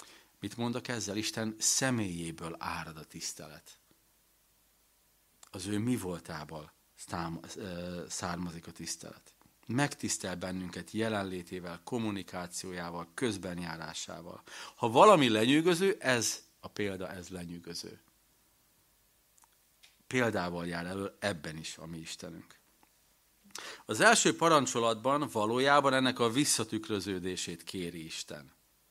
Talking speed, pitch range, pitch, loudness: 95 wpm, 85-115 Hz, 95 Hz, -32 LUFS